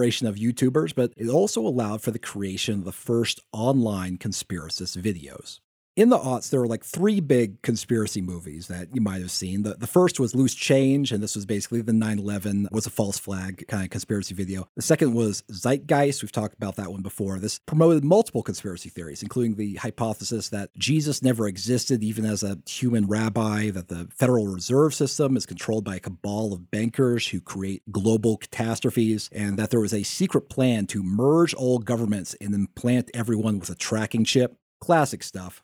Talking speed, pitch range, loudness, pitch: 190 wpm, 100-125 Hz, -25 LUFS, 110 Hz